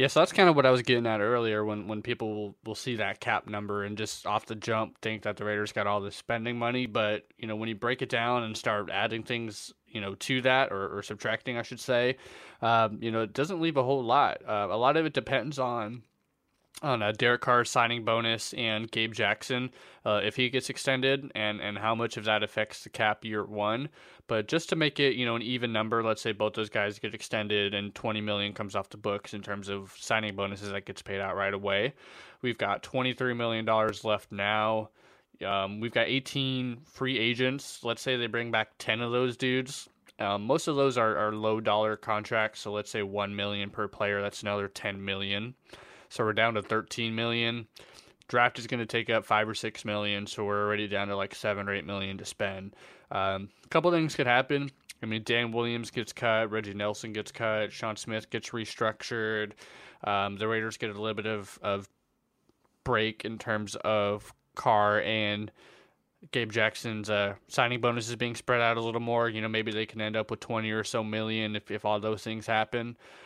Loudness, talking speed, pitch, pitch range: -30 LUFS, 220 wpm, 110 Hz, 105-120 Hz